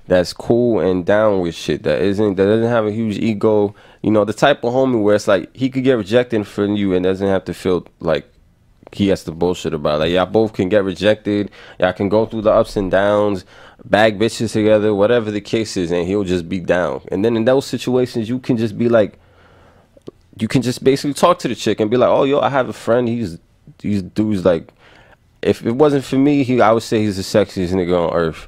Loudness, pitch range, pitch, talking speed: -17 LUFS, 95-115 Hz, 105 Hz, 240 wpm